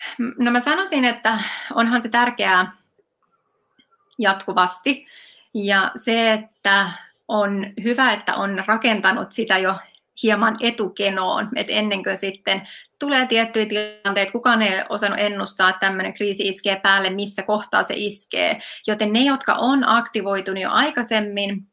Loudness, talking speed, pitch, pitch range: -19 LUFS, 130 wpm, 215 Hz, 195-240 Hz